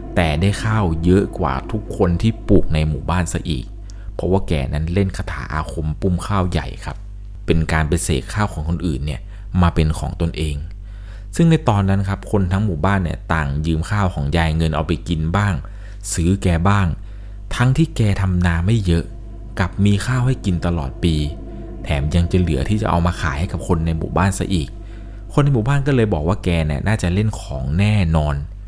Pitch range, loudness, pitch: 80-100 Hz, -19 LUFS, 90 Hz